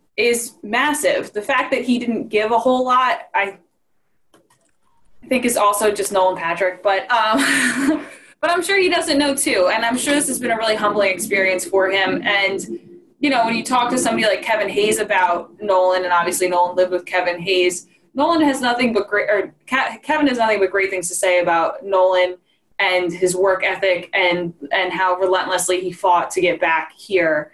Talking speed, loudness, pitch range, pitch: 195 wpm, -18 LUFS, 180-250 Hz, 200 Hz